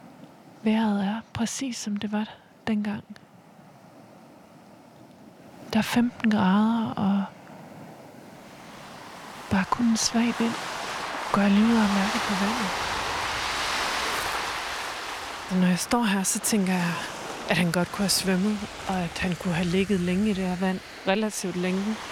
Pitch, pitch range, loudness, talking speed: 205 Hz, 185-220 Hz, -26 LUFS, 135 wpm